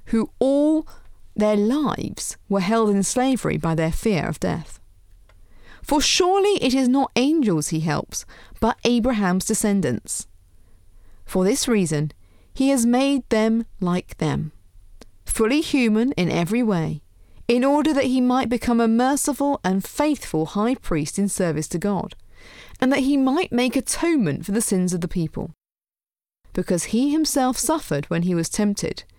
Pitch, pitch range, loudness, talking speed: 220 Hz, 170-260 Hz, -21 LUFS, 150 wpm